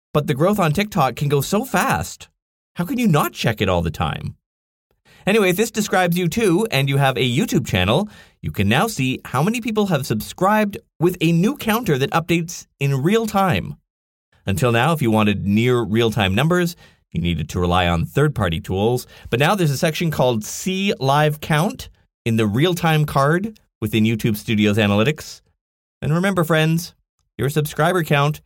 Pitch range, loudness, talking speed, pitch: 110-175 Hz, -19 LUFS, 190 wpm, 145 Hz